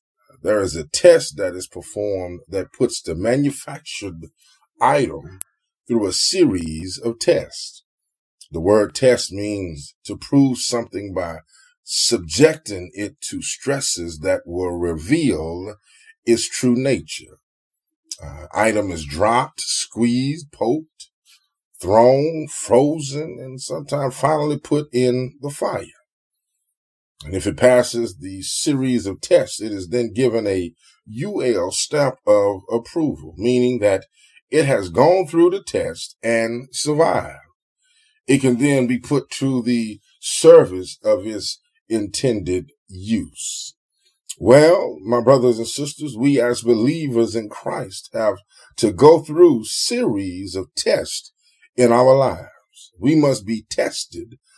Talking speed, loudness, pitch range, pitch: 125 wpm, -19 LUFS, 100-150 Hz, 125 Hz